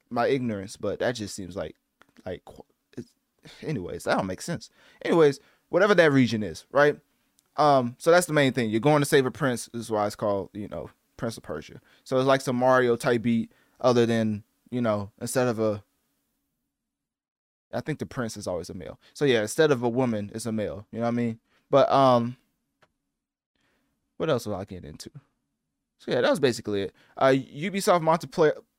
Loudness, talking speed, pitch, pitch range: -25 LUFS, 200 wpm, 120 Hz, 105-135 Hz